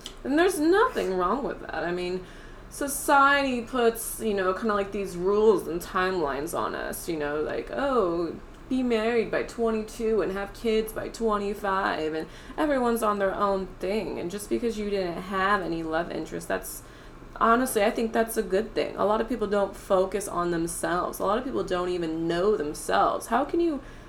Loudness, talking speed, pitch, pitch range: -26 LUFS, 190 wpm, 205 Hz, 180-230 Hz